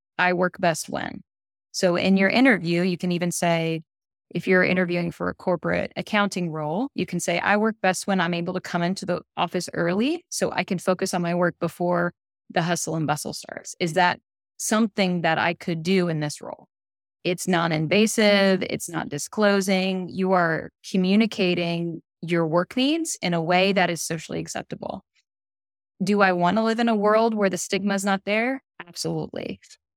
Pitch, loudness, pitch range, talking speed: 180 Hz, -23 LUFS, 170-195 Hz, 185 wpm